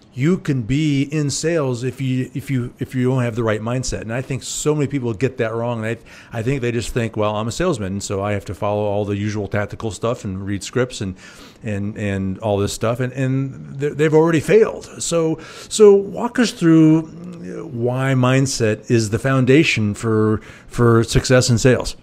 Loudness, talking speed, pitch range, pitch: -19 LUFS, 205 wpm, 110-140 Hz, 125 Hz